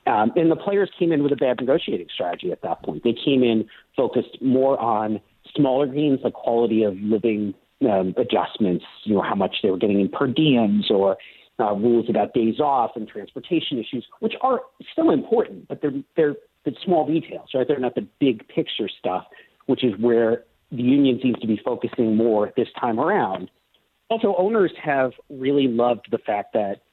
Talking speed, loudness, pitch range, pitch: 190 wpm, -22 LUFS, 115-150 Hz, 130 Hz